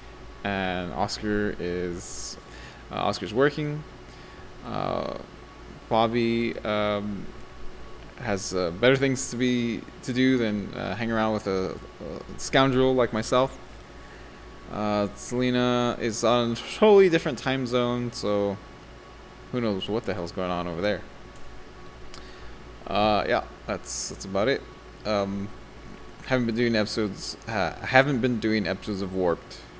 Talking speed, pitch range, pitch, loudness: 130 wpm, 100-125 Hz, 110 Hz, -26 LUFS